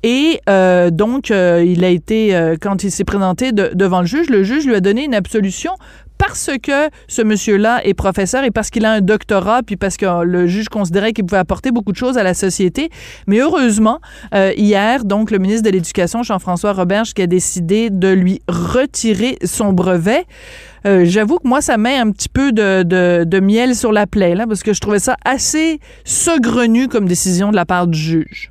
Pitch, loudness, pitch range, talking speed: 205 Hz, -14 LUFS, 190-235 Hz, 210 wpm